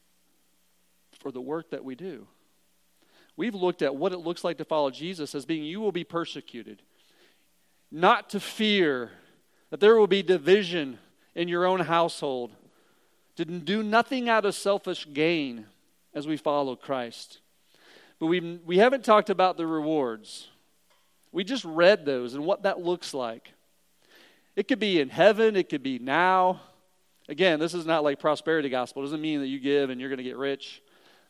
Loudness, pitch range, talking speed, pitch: -26 LUFS, 140-190 Hz, 175 wpm, 170 Hz